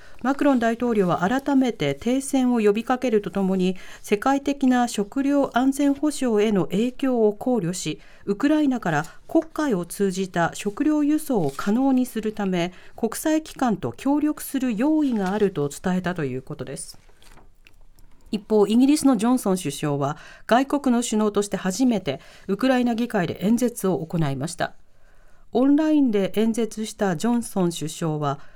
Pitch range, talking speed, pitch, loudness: 185-260 Hz, 315 characters per minute, 220 Hz, -23 LUFS